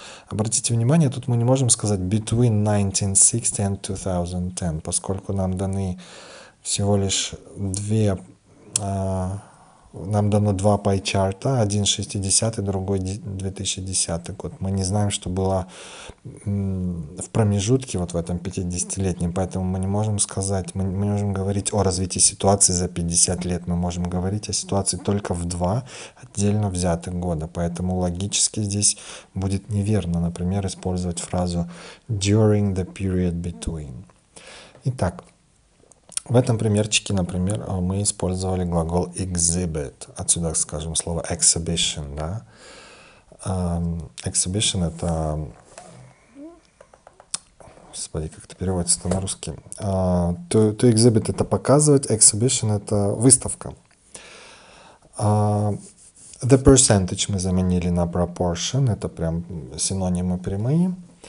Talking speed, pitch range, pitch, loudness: 115 wpm, 90-105 Hz, 95 Hz, -22 LUFS